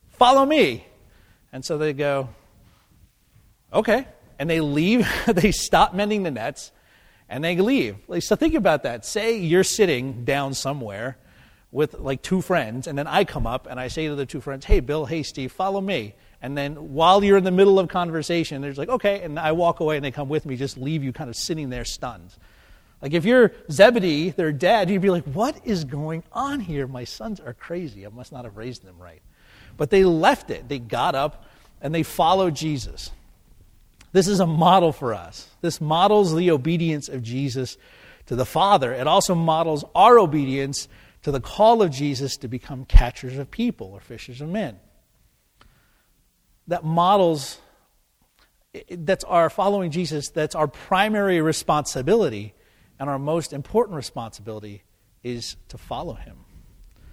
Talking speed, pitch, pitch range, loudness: 180 wpm, 150 Hz, 125-180 Hz, -22 LUFS